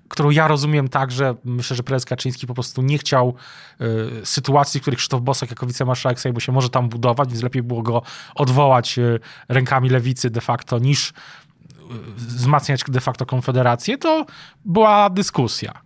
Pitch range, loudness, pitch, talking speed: 125-145 Hz, -19 LUFS, 130 Hz, 165 wpm